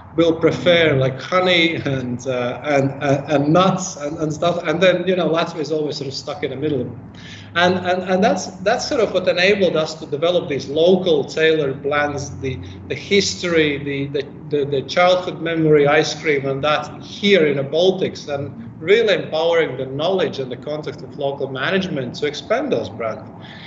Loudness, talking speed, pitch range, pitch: -18 LUFS, 190 wpm, 140-175 Hz, 150 Hz